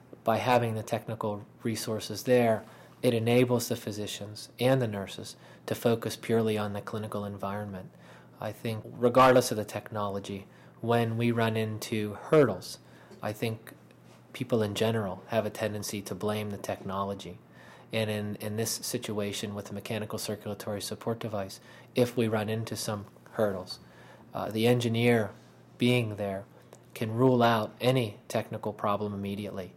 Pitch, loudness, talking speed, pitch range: 110 Hz, -30 LUFS, 145 wpm, 105-115 Hz